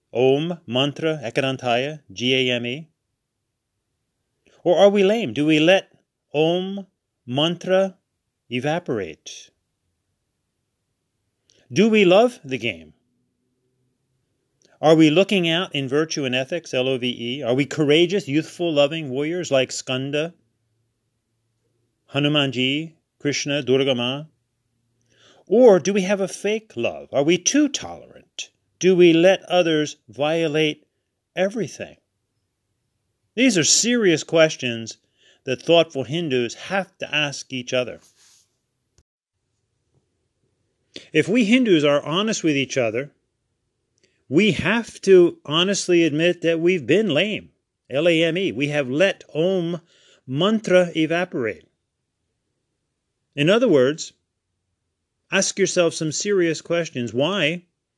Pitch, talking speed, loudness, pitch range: 145 Hz, 115 wpm, -20 LUFS, 120-175 Hz